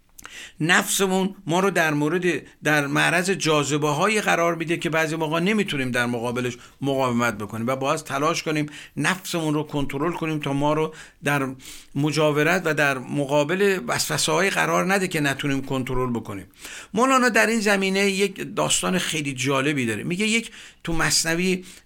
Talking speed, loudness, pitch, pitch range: 155 wpm, -22 LUFS, 155 Hz, 140-185 Hz